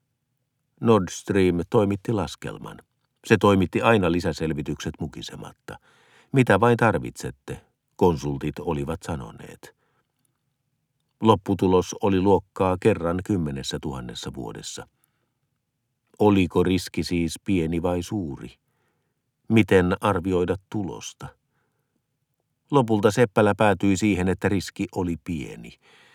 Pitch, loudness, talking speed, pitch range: 100 Hz, -23 LUFS, 85 wpm, 90-120 Hz